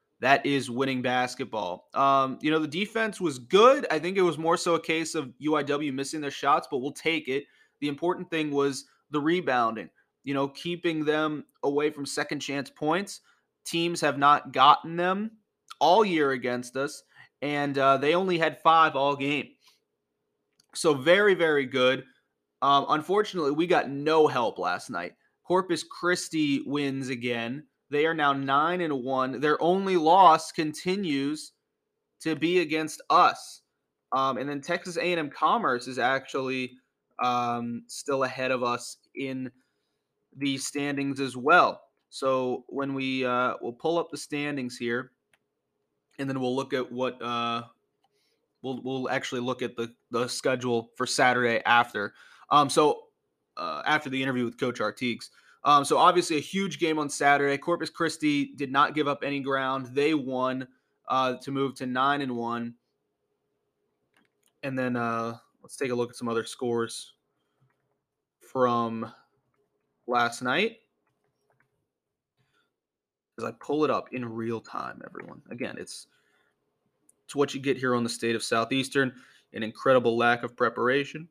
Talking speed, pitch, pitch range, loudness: 155 wpm, 140 Hz, 125-160 Hz, -26 LUFS